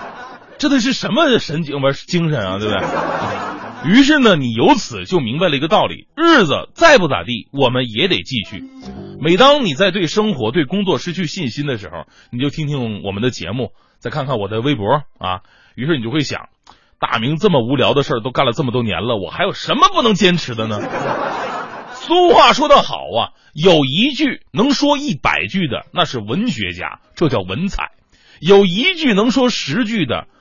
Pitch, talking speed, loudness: 155 Hz, 275 characters per minute, -15 LUFS